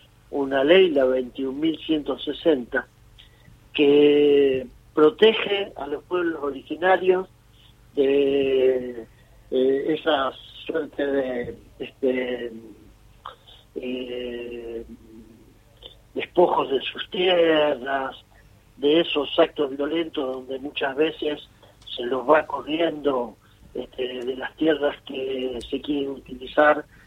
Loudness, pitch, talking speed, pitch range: -23 LUFS, 135 Hz, 85 wpm, 120-150 Hz